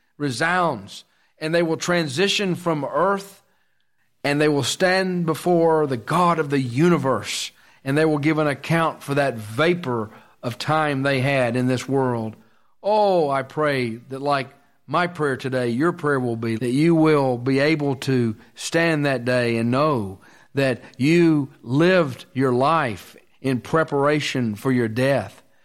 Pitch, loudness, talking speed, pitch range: 140 Hz, -21 LUFS, 155 wpm, 130-160 Hz